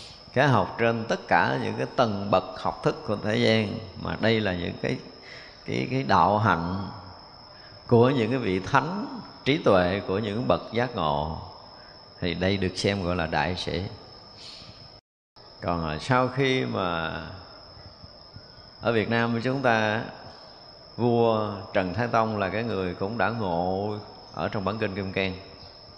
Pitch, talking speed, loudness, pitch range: 100 Hz, 155 wpm, -26 LUFS, 90-115 Hz